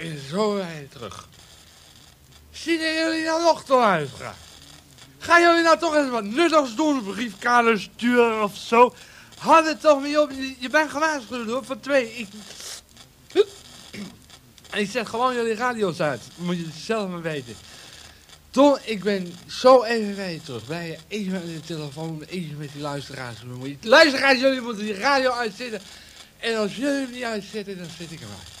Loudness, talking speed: -22 LUFS, 170 wpm